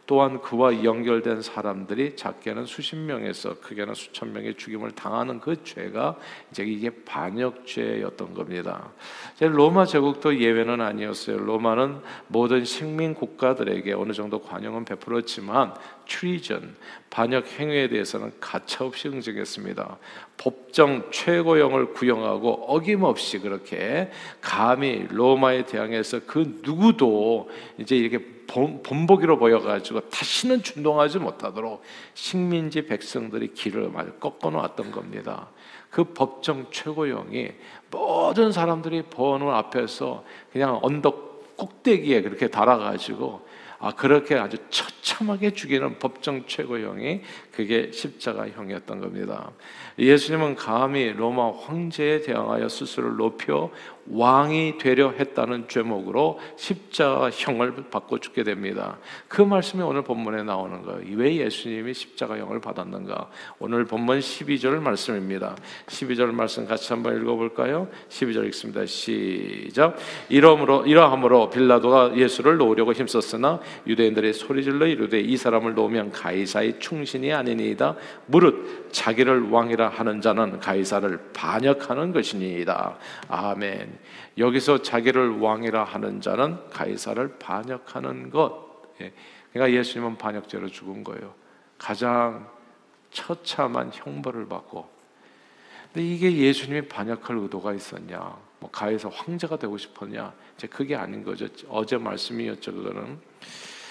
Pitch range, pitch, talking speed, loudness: 110-145 Hz, 125 Hz, 305 characters per minute, -24 LUFS